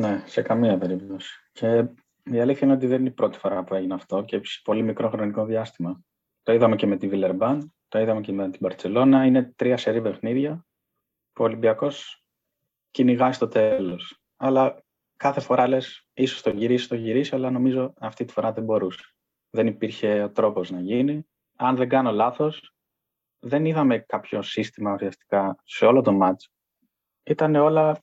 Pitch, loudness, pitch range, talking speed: 120 Hz, -23 LUFS, 105-130 Hz, 175 wpm